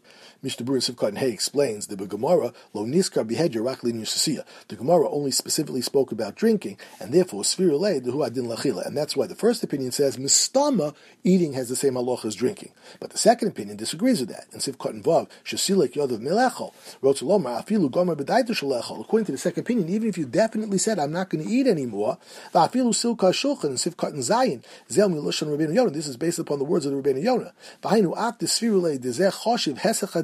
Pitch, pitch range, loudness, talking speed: 170 Hz, 140-215 Hz, -24 LUFS, 175 wpm